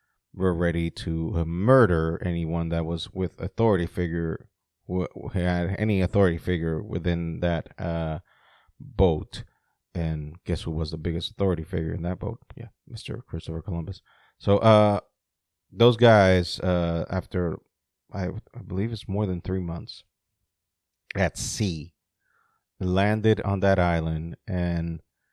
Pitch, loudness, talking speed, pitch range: 90 Hz, -25 LUFS, 130 wpm, 85-100 Hz